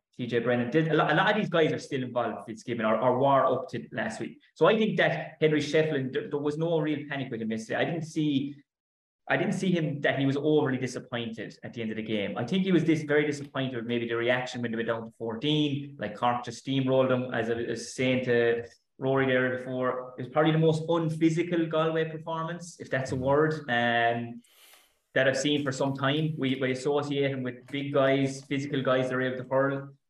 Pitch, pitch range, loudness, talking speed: 135 Hz, 120-155 Hz, -28 LUFS, 235 wpm